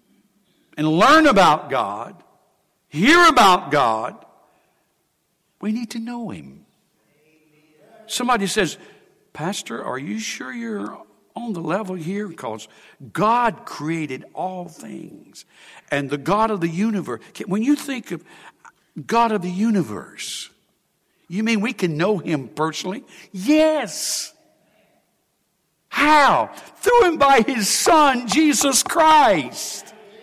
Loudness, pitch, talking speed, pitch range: -19 LUFS, 210 Hz, 115 wpm, 175-245 Hz